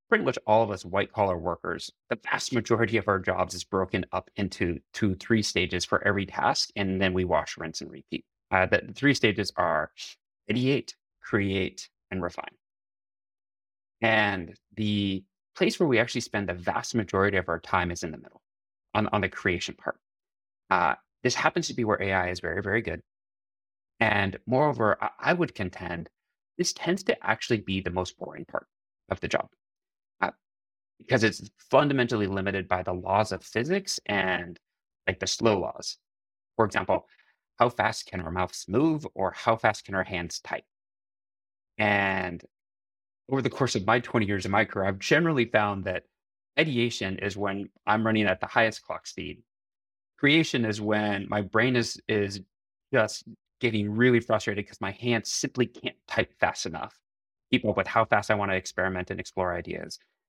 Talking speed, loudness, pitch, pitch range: 175 wpm, -27 LUFS, 100 Hz, 95-115 Hz